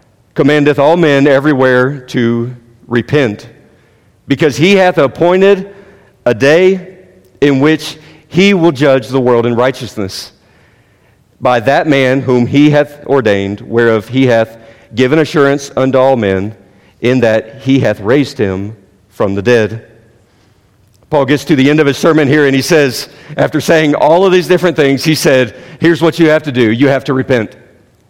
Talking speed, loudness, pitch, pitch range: 160 wpm, -10 LUFS, 130 Hz, 115-150 Hz